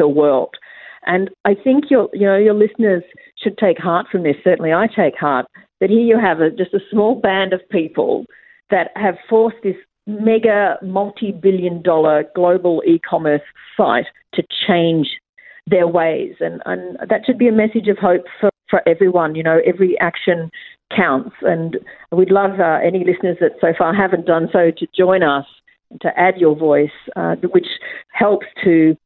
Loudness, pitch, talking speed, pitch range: -16 LUFS, 185 Hz, 170 wpm, 170-210 Hz